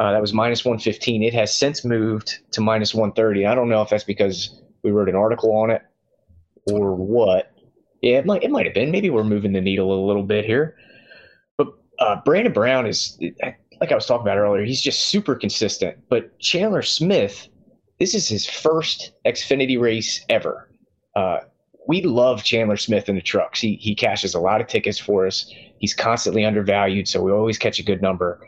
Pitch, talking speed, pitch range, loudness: 110 Hz, 200 wpm, 100-115 Hz, -20 LUFS